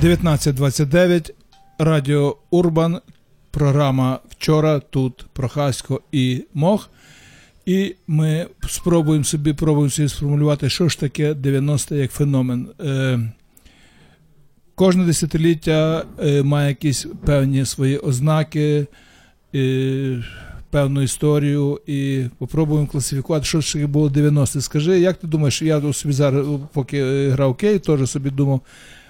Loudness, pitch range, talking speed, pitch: -19 LUFS, 135-155 Hz, 105 wpm, 145 Hz